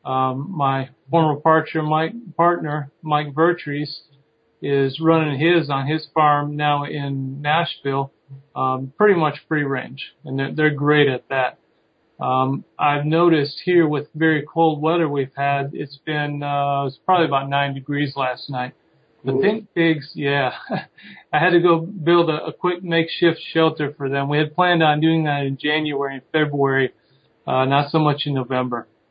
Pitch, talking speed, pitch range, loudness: 150 Hz, 160 wpm, 140-160 Hz, -20 LUFS